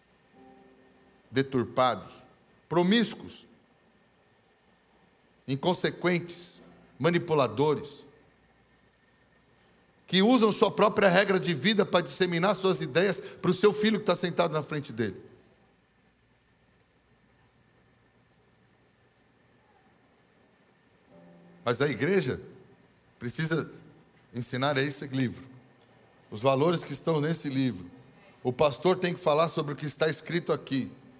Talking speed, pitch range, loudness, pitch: 95 wpm, 130-180 Hz, -27 LUFS, 150 Hz